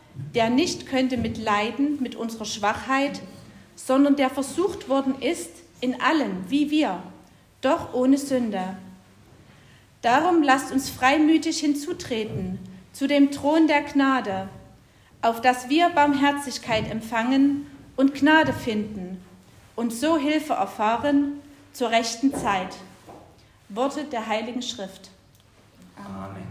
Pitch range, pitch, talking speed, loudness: 215-285 Hz, 260 Hz, 115 wpm, -23 LUFS